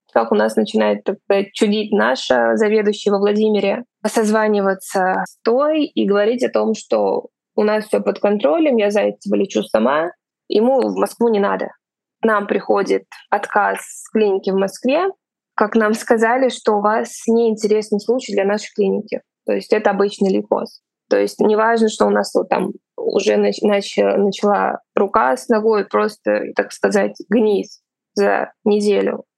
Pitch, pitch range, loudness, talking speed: 210 Hz, 195-220 Hz, -17 LUFS, 155 wpm